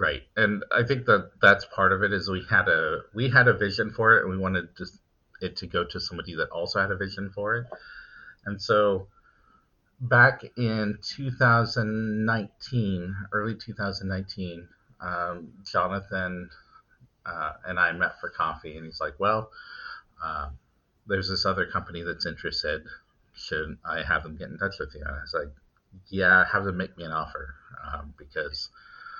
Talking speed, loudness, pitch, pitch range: 175 wpm, -26 LUFS, 100 Hz, 95-115 Hz